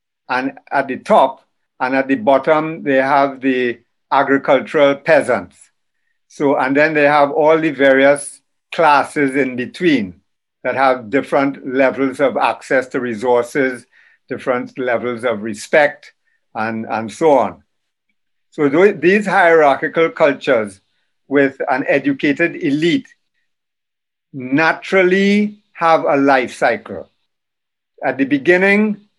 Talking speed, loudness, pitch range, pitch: 115 wpm, -15 LUFS, 130-165 Hz, 140 Hz